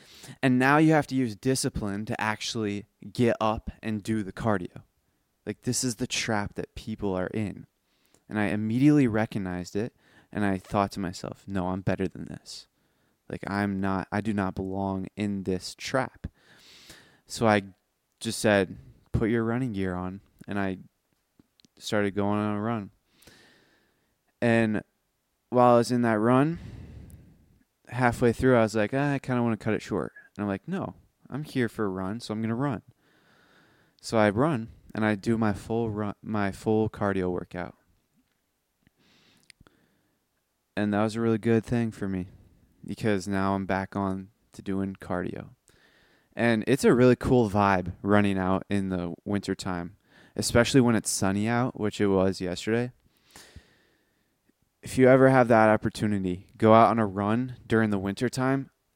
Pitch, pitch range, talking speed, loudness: 105 Hz, 95-120 Hz, 165 wpm, -26 LUFS